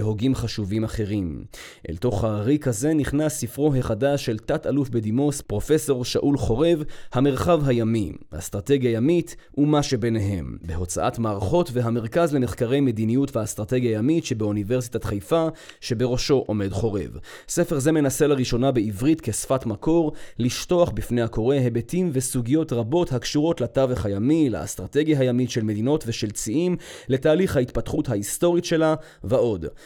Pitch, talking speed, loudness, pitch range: 125 Hz, 125 wpm, -23 LUFS, 110-150 Hz